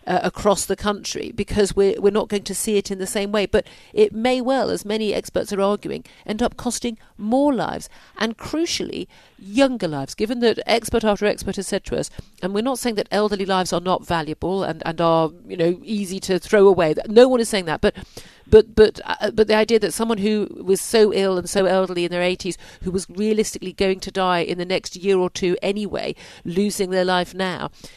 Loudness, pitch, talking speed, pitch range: -20 LUFS, 200 Hz, 220 wpm, 185-215 Hz